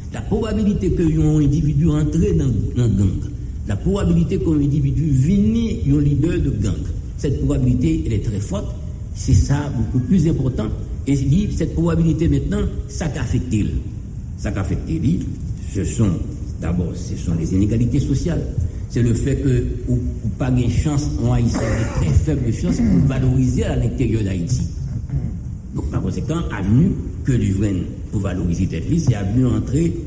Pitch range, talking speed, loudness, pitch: 100-145 Hz, 155 wpm, -20 LUFS, 120 Hz